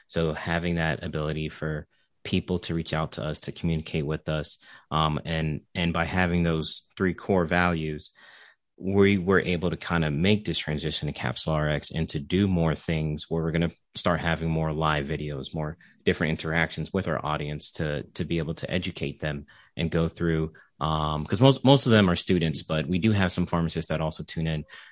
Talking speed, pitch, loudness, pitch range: 200 wpm, 80 Hz, -27 LUFS, 75-90 Hz